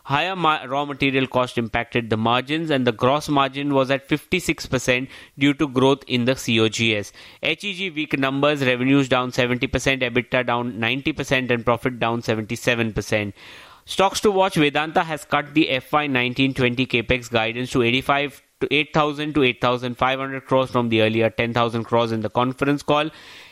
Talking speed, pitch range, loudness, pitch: 155 wpm, 120-145 Hz, -21 LUFS, 130 Hz